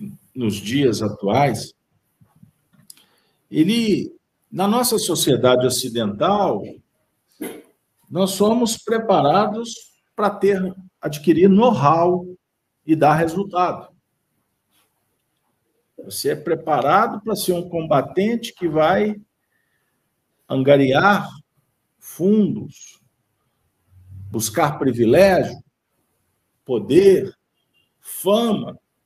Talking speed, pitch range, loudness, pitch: 70 wpm, 140-205 Hz, -18 LUFS, 180 Hz